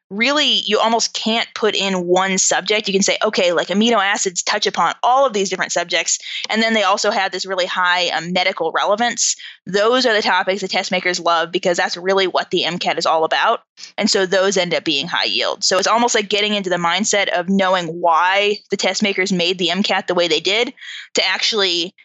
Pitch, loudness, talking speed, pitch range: 195 Hz, -16 LUFS, 220 wpm, 180-215 Hz